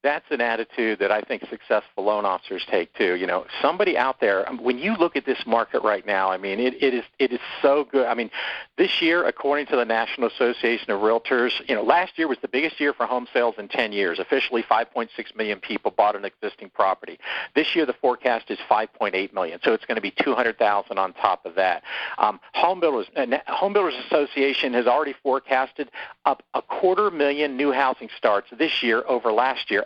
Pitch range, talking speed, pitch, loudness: 115-145 Hz, 210 wpm, 130 Hz, -23 LUFS